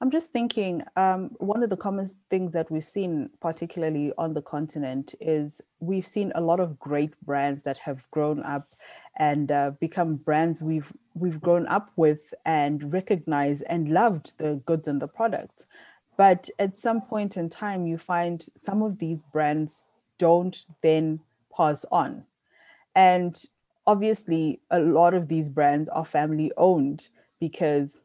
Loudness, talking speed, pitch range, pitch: -25 LUFS, 155 wpm, 150-190 Hz, 165 Hz